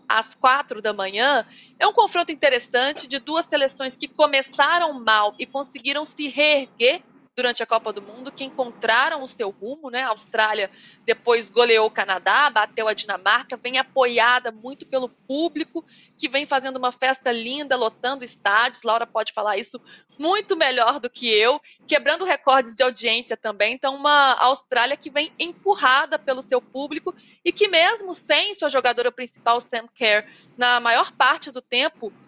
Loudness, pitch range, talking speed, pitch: -20 LUFS, 230-290 Hz, 165 wpm, 255 Hz